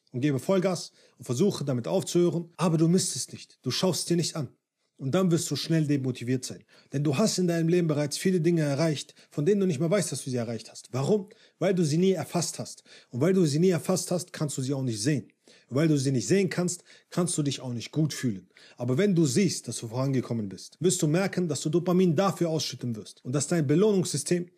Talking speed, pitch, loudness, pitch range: 245 wpm, 160 Hz, -27 LUFS, 135-180 Hz